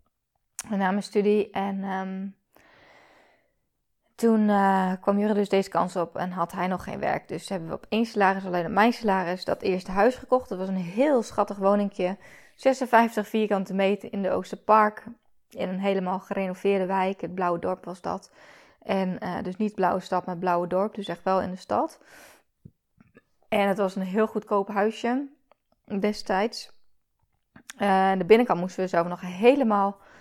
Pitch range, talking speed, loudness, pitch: 185-215 Hz, 175 wpm, -25 LUFS, 195 Hz